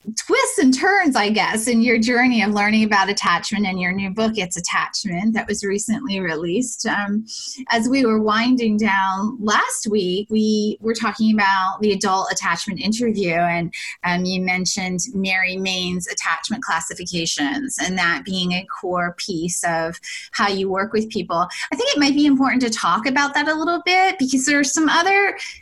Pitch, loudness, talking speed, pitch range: 210 Hz, -19 LUFS, 180 wpm, 185-250 Hz